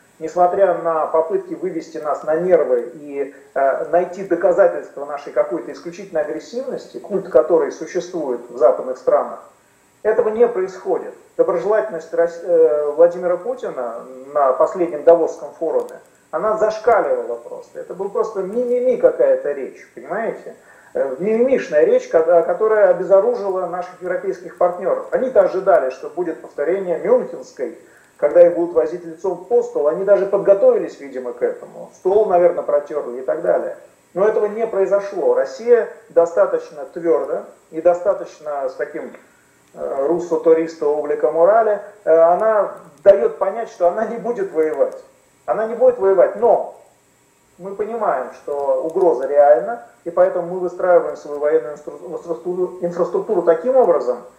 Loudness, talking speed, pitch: -18 LUFS, 125 wpm, 195 Hz